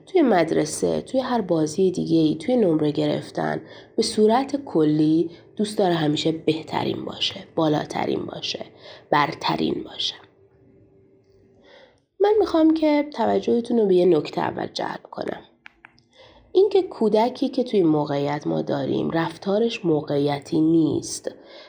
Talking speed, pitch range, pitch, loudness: 120 wpm, 150-240 Hz, 170 Hz, -22 LUFS